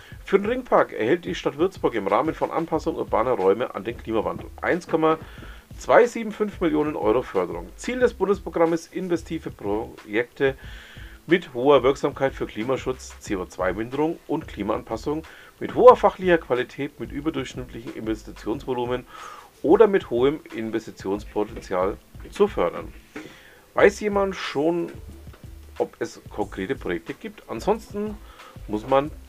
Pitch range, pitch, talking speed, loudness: 115-195 Hz, 150 Hz, 115 wpm, -24 LUFS